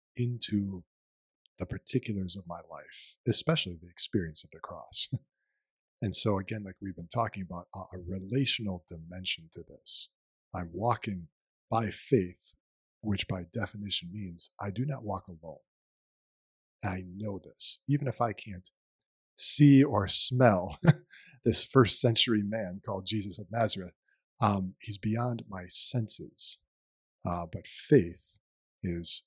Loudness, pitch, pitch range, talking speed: -30 LUFS, 100 Hz, 90-110 Hz, 135 wpm